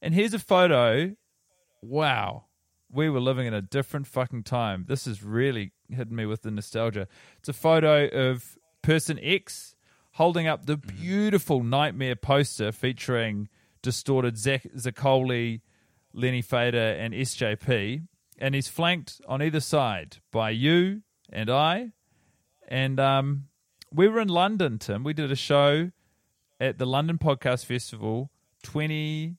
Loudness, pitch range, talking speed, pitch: -26 LUFS, 115-155 Hz, 140 wpm, 135 Hz